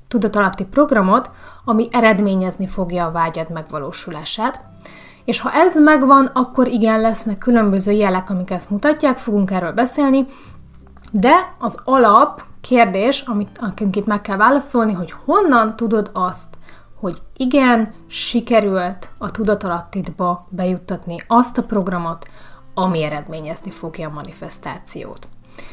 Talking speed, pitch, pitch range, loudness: 115 wpm, 210 Hz, 185-245 Hz, -17 LUFS